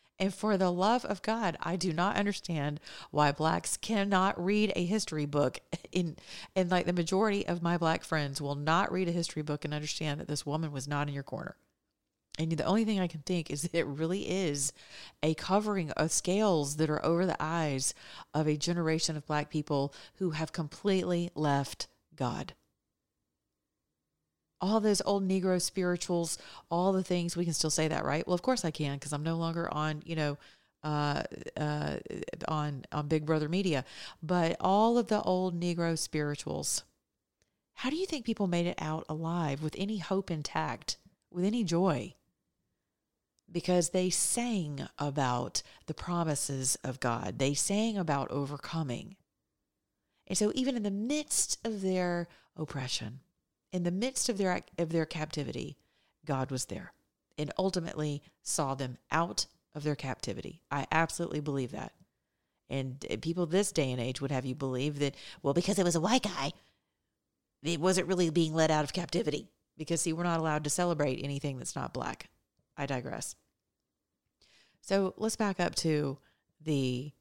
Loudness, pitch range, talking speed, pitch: -32 LUFS, 150-185 Hz, 170 wpm, 165 Hz